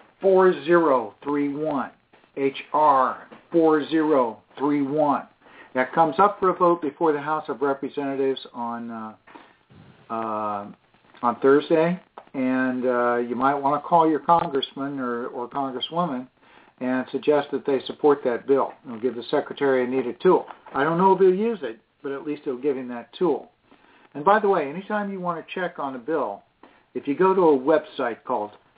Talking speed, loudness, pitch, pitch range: 165 wpm, -23 LUFS, 140 Hz, 130-165 Hz